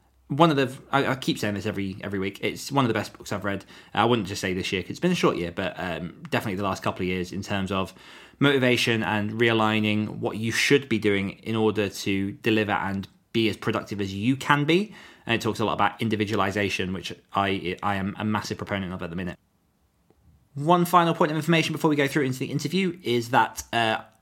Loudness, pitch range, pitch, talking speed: -25 LUFS, 95-130 Hz, 110 Hz, 235 wpm